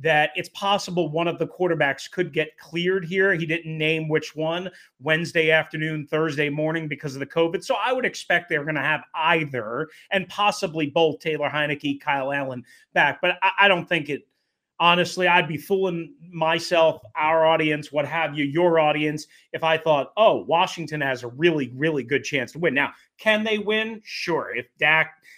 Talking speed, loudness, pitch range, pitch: 185 wpm, -22 LUFS, 150-175 Hz, 160 Hz